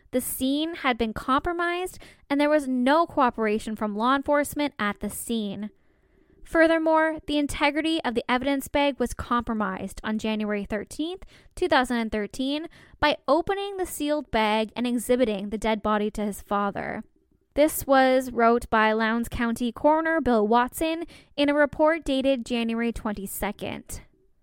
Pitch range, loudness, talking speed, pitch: 220-295 Hz, -25 LUFS, 140 wpm, 255 Hz